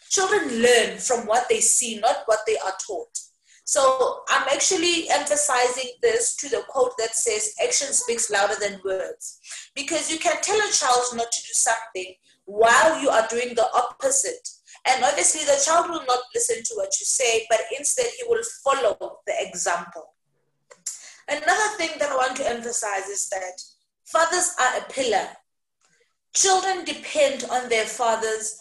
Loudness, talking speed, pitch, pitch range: -22 LUFS, 165 wpm, 260 Hz, 225-340 Hz